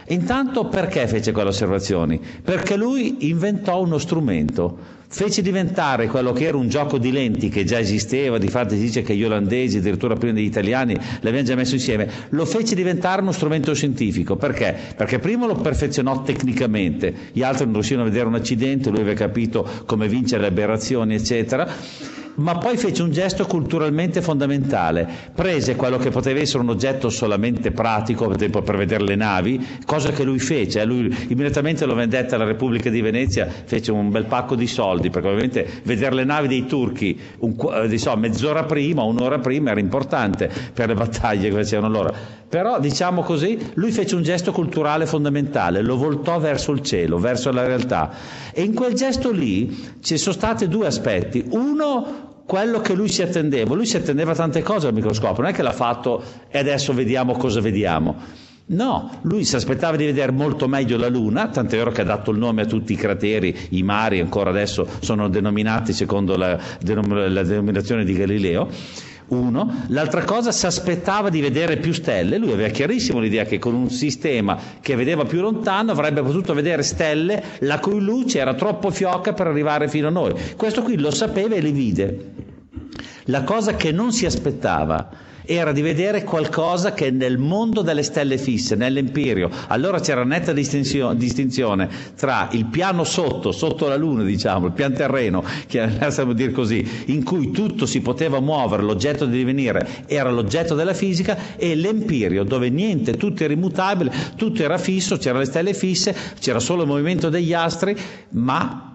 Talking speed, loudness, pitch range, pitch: 180 wpm, -20 LUFS, 115-170 Hz, 135 Hz